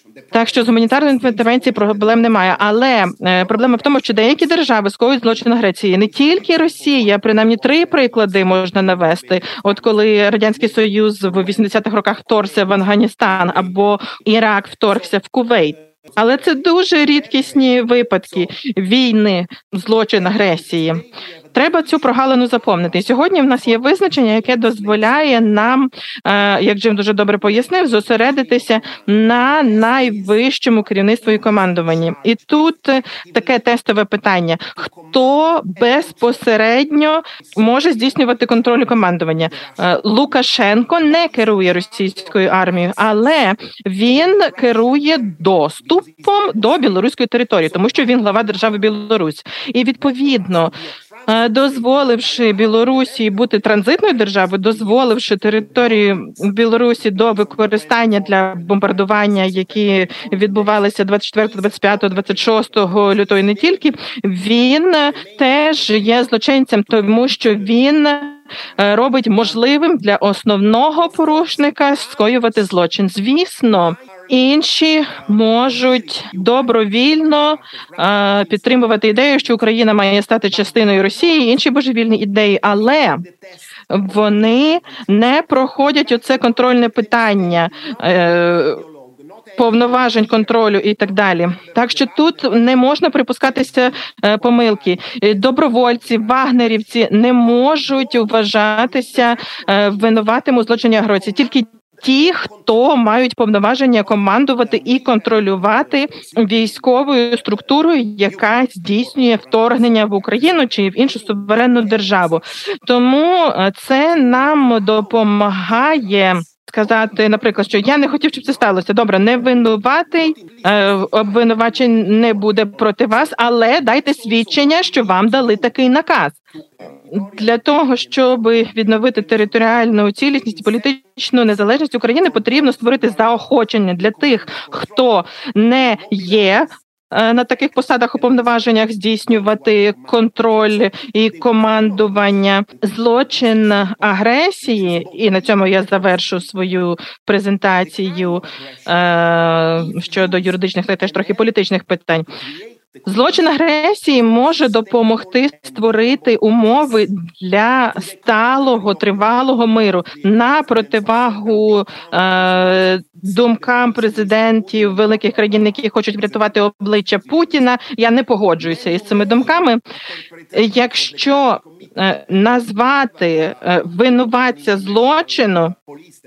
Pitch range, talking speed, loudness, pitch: 205-255 Hz, 105 wpm, -13 LUFS, 225 Hz